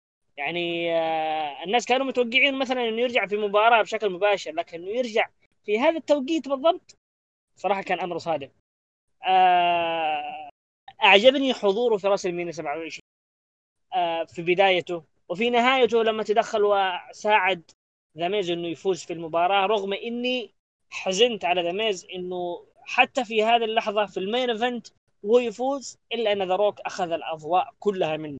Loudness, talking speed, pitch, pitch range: -24 LUFS, 130 wpm, 205 Hz, 175-240 Hz